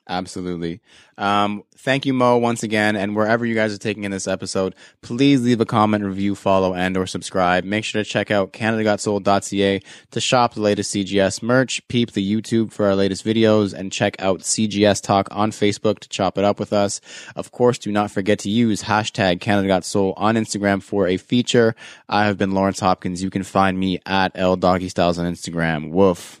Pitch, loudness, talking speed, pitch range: 100 Hz, -20 LUFS, 195 wpm, 95-110 Hz